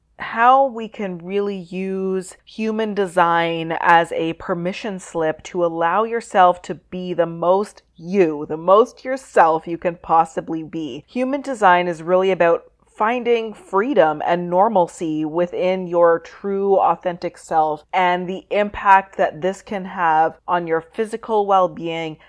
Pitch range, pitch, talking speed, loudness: 165-200 Hz, 180 Hz, 140 wpm, -19 LUFS